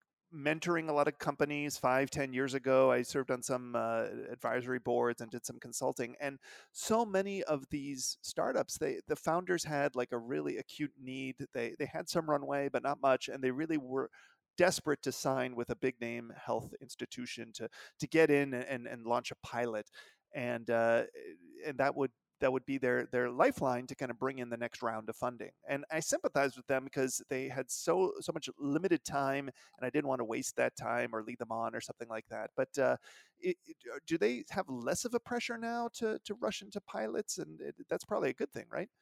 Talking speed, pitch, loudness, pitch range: 215 wpm, 135 Hz, -36 LUFS, 125-155 Hz